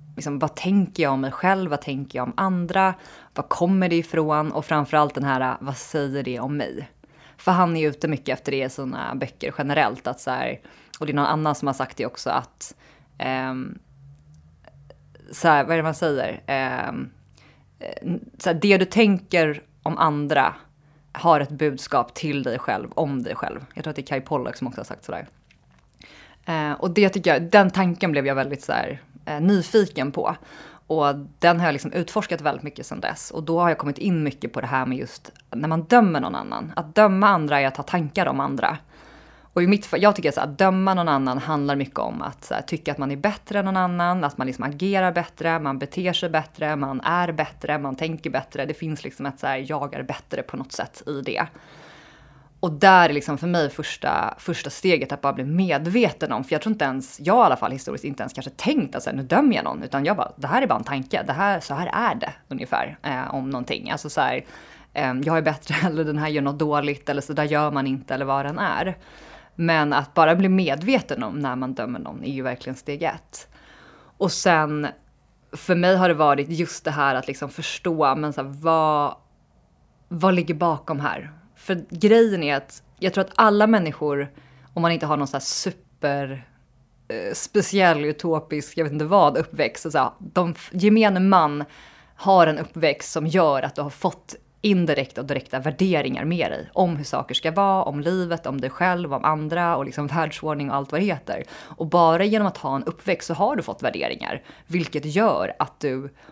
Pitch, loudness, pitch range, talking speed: 155 Hz, -22 LUFS, 140-180 Hz, 215 wpm